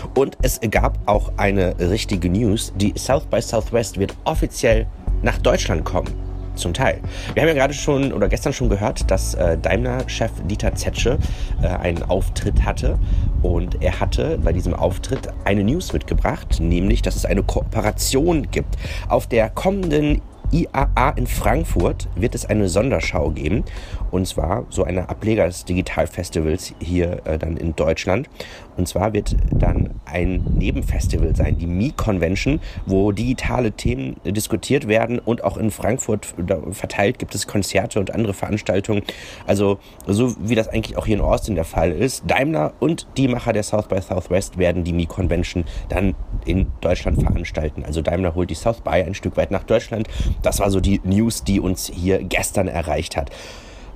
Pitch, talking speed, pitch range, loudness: 95 Hz, 165 wpm, 90-110 Hz, -21 LUFS